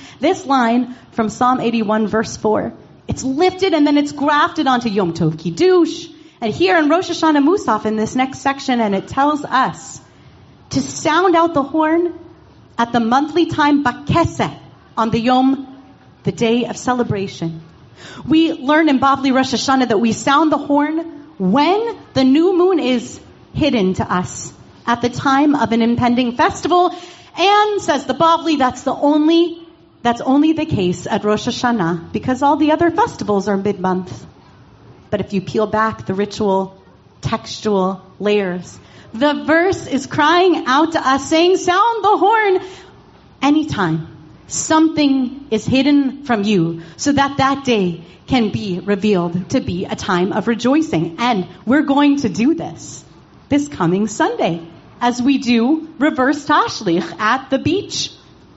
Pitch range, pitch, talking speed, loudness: 215-310 Hz, 265 Hz, 155 wpm, -16 LUFS